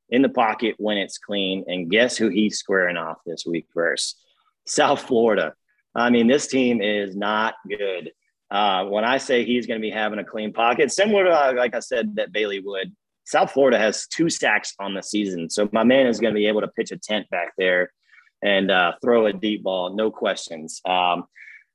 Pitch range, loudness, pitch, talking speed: 95-115 Hz, -21 LUFS, 105 Hz, 210 wpm